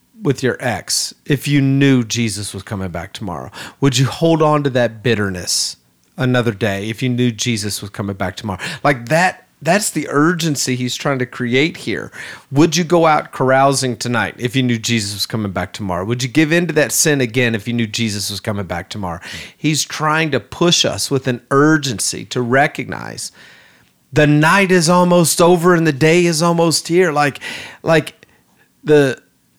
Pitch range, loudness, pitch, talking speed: 110-155 Hz, -16 LUFS, 130 Hz, 185 wpm